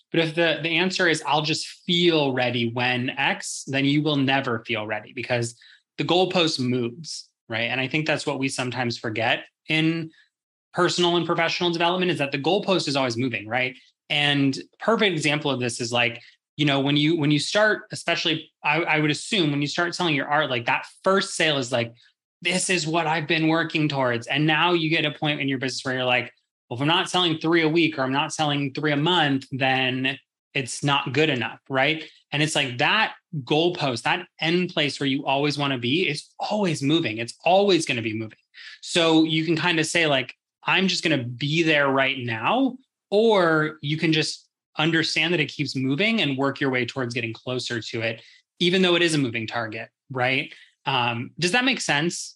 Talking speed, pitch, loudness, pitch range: 210 wpm, 150 Hz, -23 LUFS, 130-165 Hz